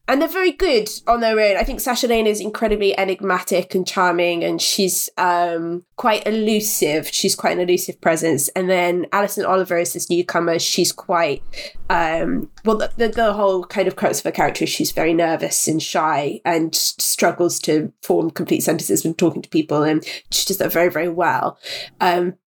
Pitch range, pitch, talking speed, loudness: 175-210 Hz, 185 Hz, 190 wpm, -19 LUFS